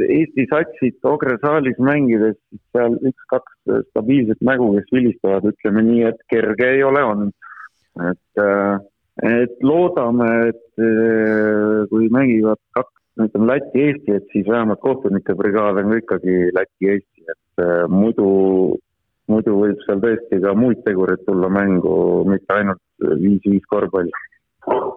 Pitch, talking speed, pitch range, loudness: 110 Hz, 125 wpm, 100-120 Hz, -17 LUFS